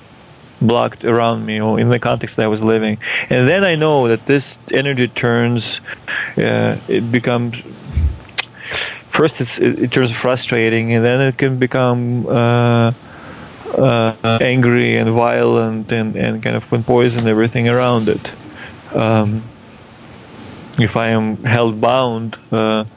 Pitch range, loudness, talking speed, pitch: 110-125 Hz, -16 LUFS, 140 wpm, 120 Hz